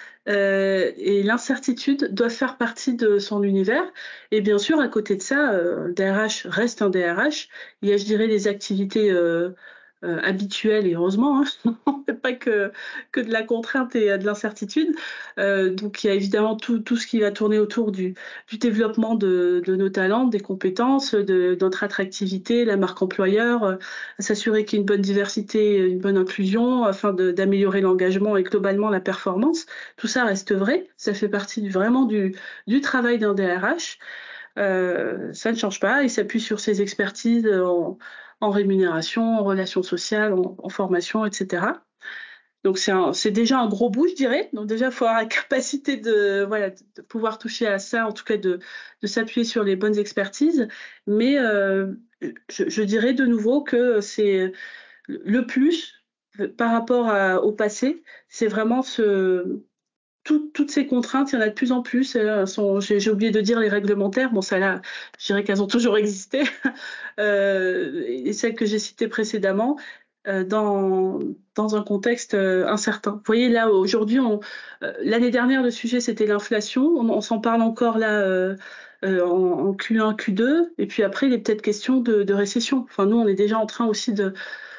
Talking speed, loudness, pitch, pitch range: 190 wpm, -22 LUFS, 215 Hz, 200-245 Hz